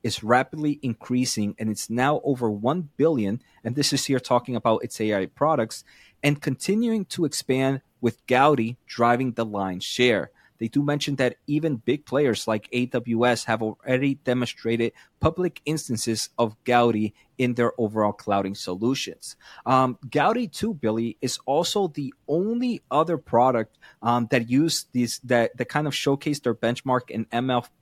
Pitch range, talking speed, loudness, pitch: 115-145 Hz, 155 wpm, -24 LUFS, 125 Hz